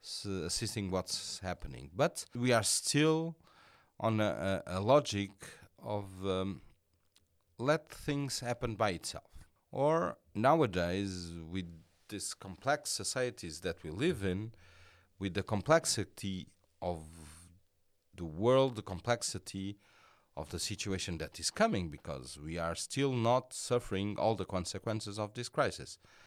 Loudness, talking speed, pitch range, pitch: -35 LUFS, 125 wpm, 90-115 Hz, 100 Hz